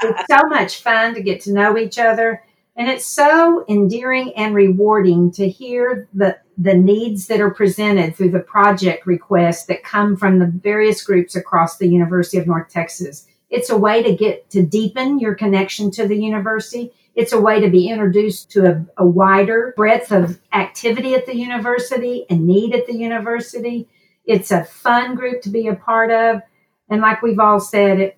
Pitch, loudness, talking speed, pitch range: 210 Hz, -16 LUFS, 185 wpm, 195-230 Hz